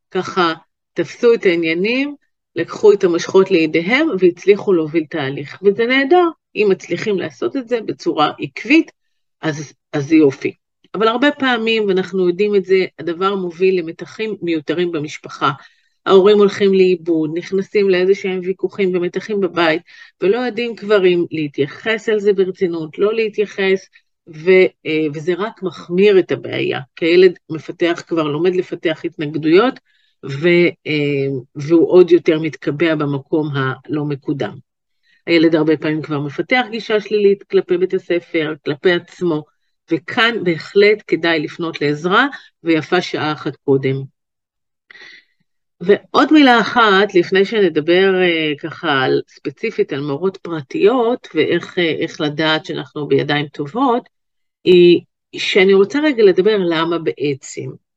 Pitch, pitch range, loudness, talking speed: 185 Hz, 160-215 Hz, -16 LUFS, 120 wpm